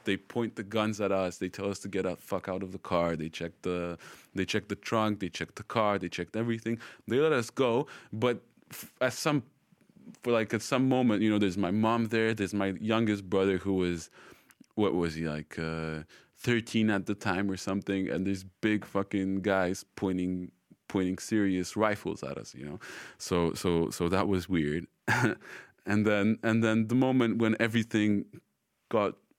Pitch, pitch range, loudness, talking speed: 100 Hz, 95-110 Hz, -30 LUFS, 195 wpm